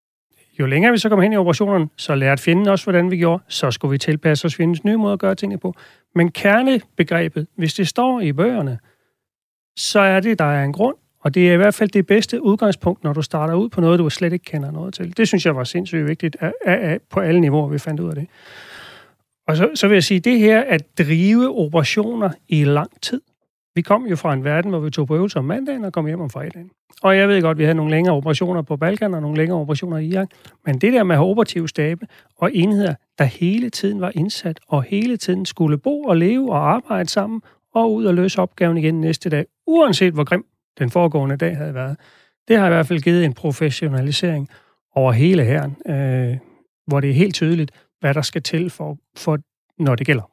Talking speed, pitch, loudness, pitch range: 235 wpm, 170 Hz, -18 LUFS, 155-195 Hz